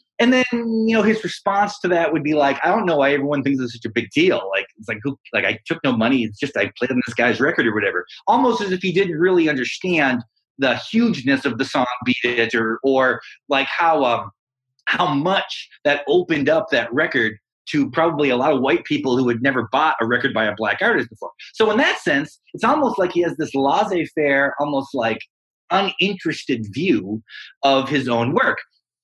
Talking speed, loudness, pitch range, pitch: 215 wpm, -19 LUFS, 125-185 Hz, 140 Hz